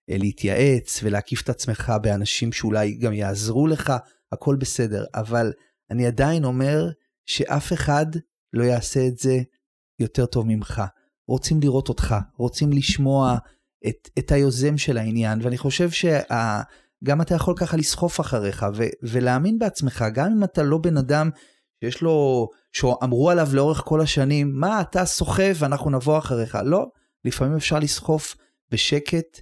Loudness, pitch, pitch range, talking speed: -22 LUFS, 135 Hz, 115-155 Hz, 140 wpm